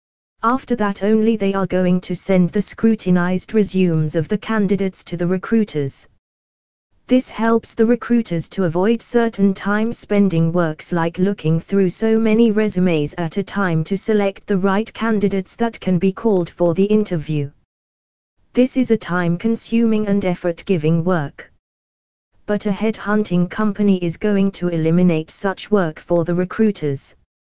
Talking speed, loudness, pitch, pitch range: 145 wpm, -18 LUFS, 190 Hz, 170-215 Hz